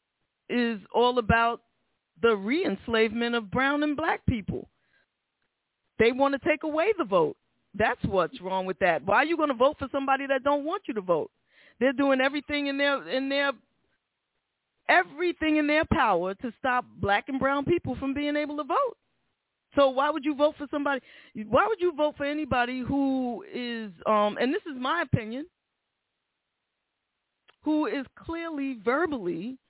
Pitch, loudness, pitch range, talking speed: 275 Hz, -27 LUFS, 240-300 Hz, 170 wpm